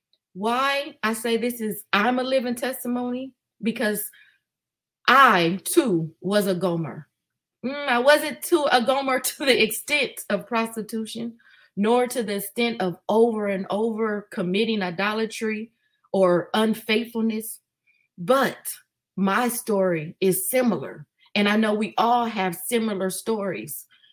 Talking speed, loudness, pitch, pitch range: 125 wpm, -23 LUFS, 220 Hz, 195-245 Hz